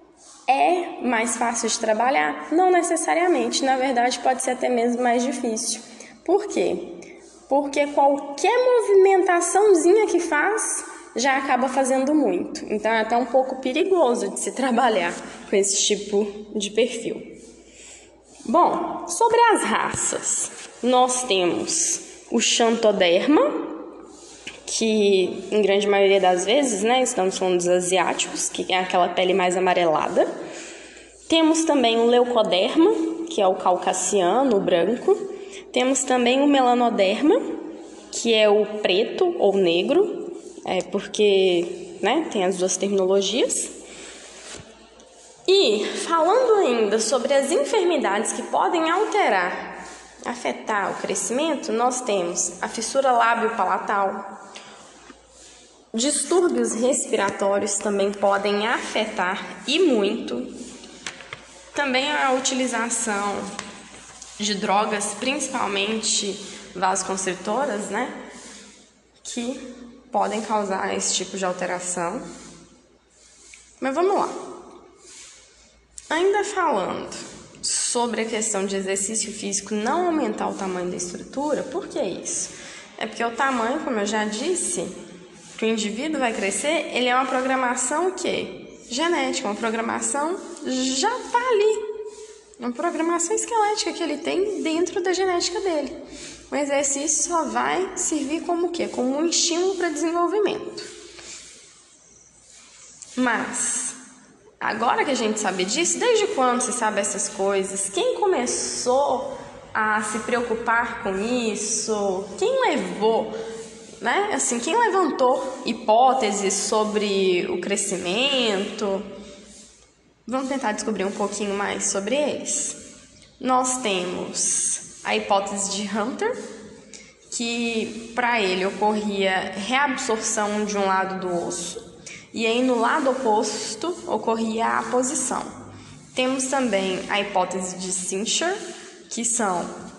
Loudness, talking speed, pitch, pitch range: -22 LUFS, 115 wpm, 245 Hz, 205-330 Hz